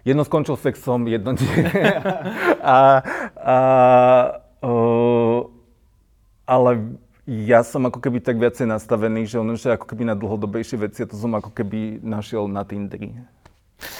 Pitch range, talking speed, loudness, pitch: 110-125 Hz, 135 wpm, -19 LUFS, 120 Hz